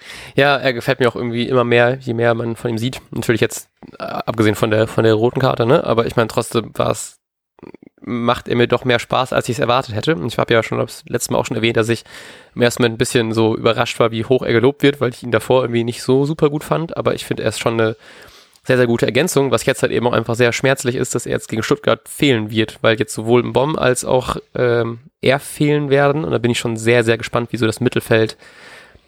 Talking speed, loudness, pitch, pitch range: 255 wpm, -17 LUFS, 120 Hz, 115-130 Hz